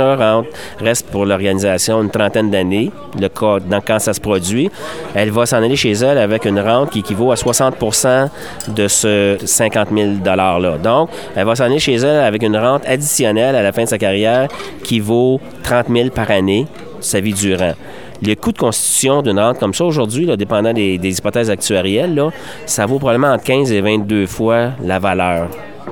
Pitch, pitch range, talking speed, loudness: 110 Hz, 100-125 Hz, 190 wpm, -14 LUFS